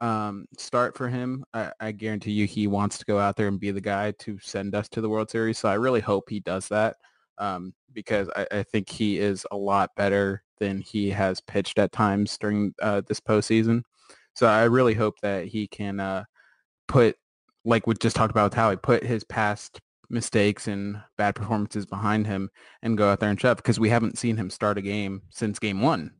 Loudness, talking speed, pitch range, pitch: -25 LUFS, 215 wpm, 100-110 Hz, 105 Hz